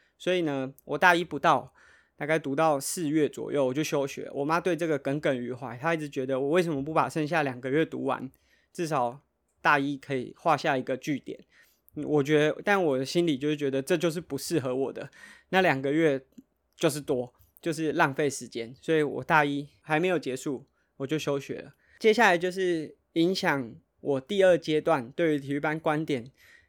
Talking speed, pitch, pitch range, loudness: 285 characters per minute, 150 Hz, 135-165 Hz, -27 LUFS